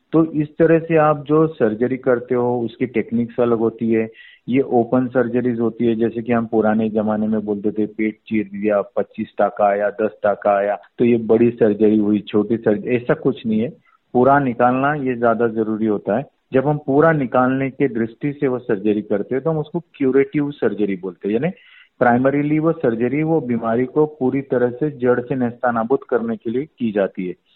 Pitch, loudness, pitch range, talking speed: 120 Hz, -19 LUFS, 110-135 Hz, 200 wpm